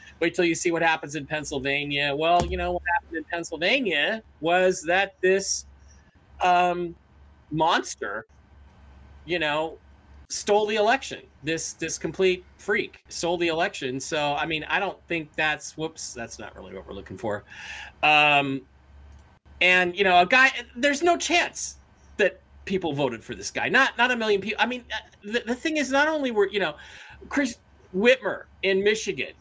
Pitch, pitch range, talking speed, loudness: 170 Hz, 140-205 Hz, 165 wpm, -24 LUFS